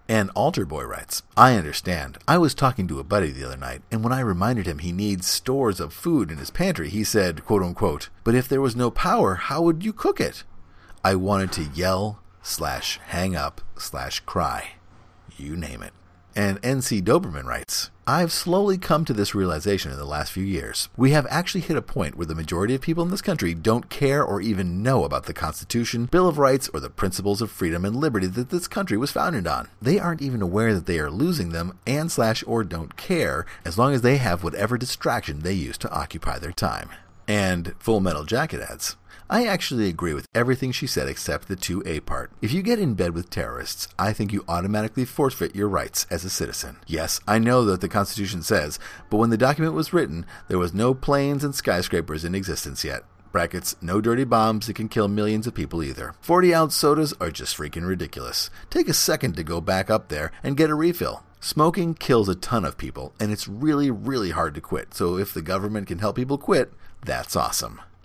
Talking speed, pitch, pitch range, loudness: 215 wpm, 105 Hz, 90-130 Hz, -24 LUFS